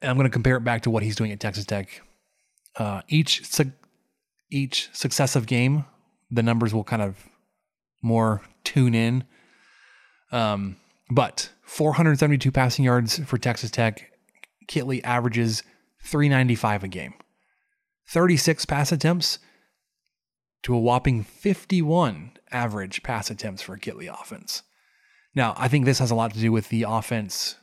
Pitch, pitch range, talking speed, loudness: 125 Hz, 115-150 Hz, 145 wpm, -24 LUFS